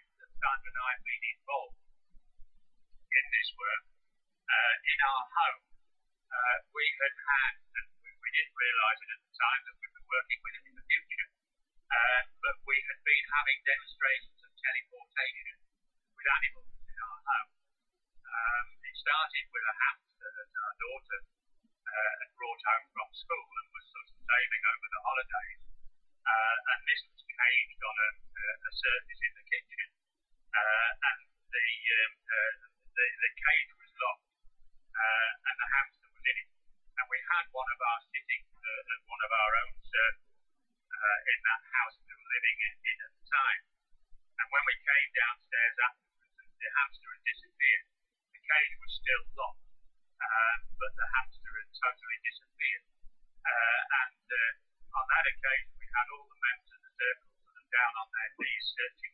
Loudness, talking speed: -31 LUFS, 165 wpm